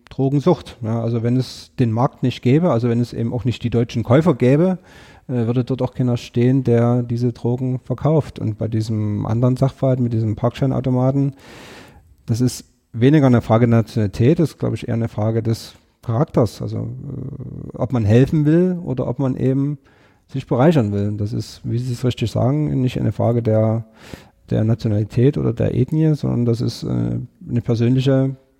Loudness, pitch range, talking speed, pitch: -19 LUFS, 115-135 Hz, 185 wpm, 120 Hz